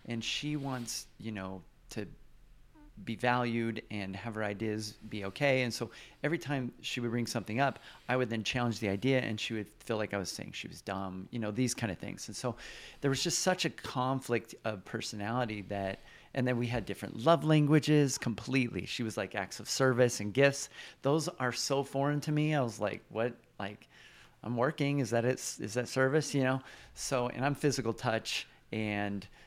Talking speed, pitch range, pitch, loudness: 205 wpm, 105-135 Hz, 120 Hz, -33 LUFS